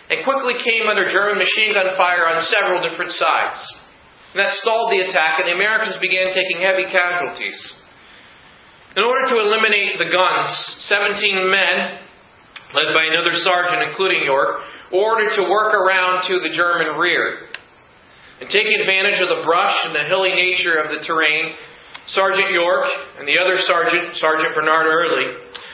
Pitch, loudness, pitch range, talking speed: 185 Hz, -16 LUFS, 175-205 Hz, 160 wpm